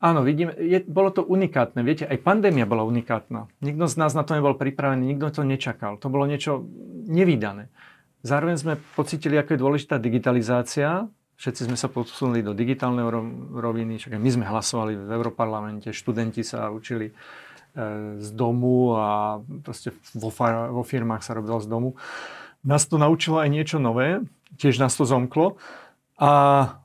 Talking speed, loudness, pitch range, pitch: 155 wpm, -23 LUFS, 115-150 Hz, 130 Hz